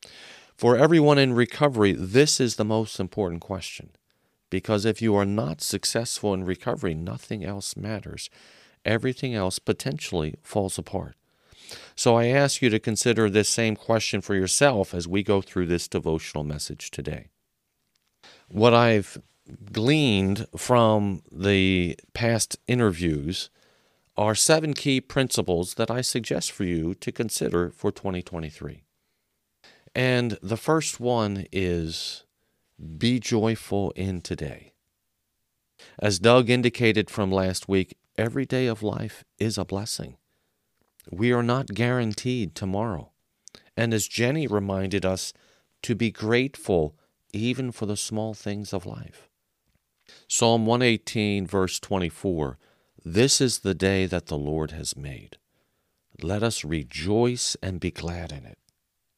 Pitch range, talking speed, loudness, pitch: 95-120 Hz, 130 wpm, -25 LUFS, 105 Hz